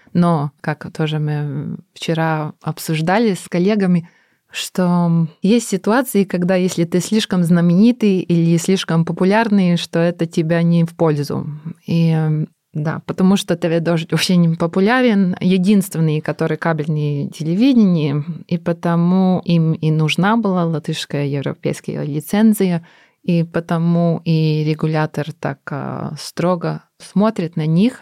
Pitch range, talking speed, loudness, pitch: 160-185 Hz, 120 wpm, -17 LUFS, 170 Hz